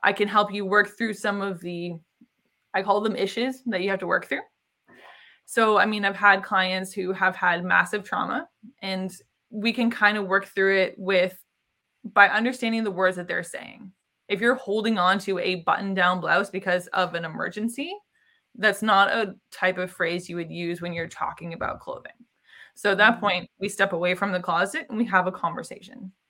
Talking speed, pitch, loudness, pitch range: 200 wpm, 200 Hz, -24 LUFS, 185-220 Hz